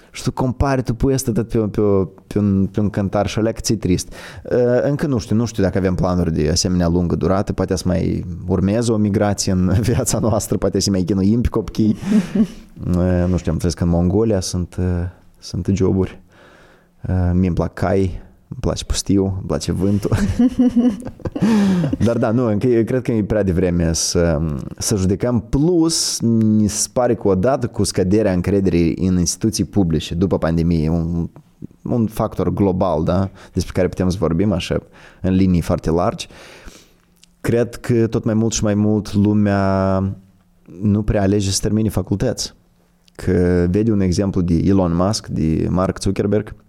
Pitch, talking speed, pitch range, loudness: 100 Hz, 160 wpm, 90-110 Hz, -18 LUFS